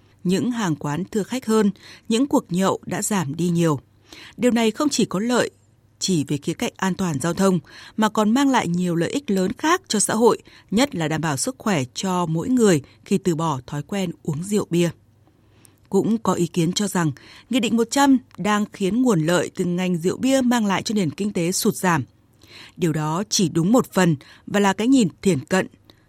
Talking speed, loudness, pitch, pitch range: 215 wpm, -21 LUFS, 185 Hz, 160-215 Hz